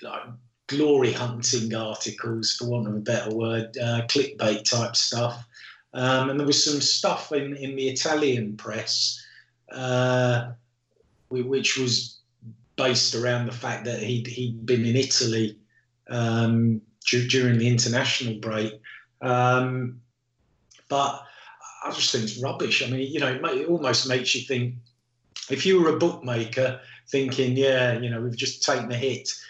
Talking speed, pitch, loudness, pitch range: 155 wpm, 125 Hz, -24 LUFS, 115-130 Hz